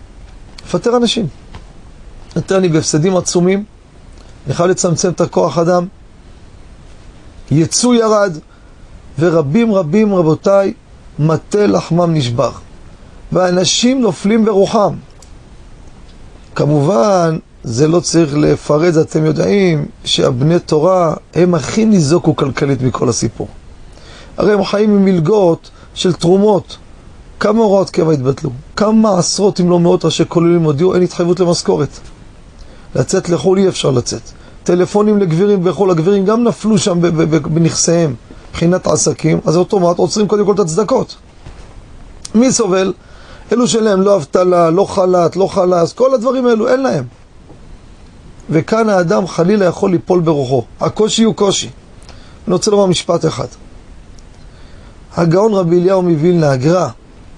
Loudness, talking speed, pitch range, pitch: -13 LUFS, 120 wpm, 150-195 Hz, 175 Hz